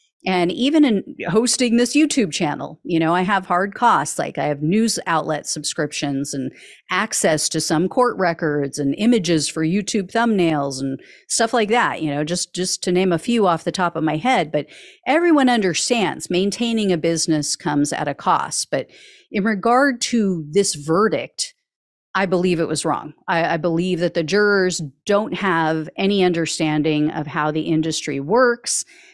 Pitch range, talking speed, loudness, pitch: 155-225 Hz, 175 wpm, -19 LUFS, 175 Hz